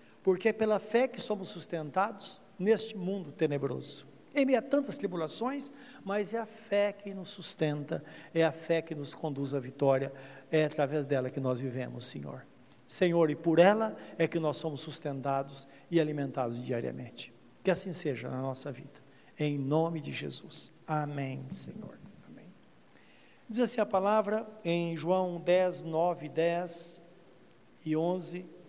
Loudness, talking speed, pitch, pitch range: -32 LUFS, 155 wpm, 165 Hz, 140-195 Hz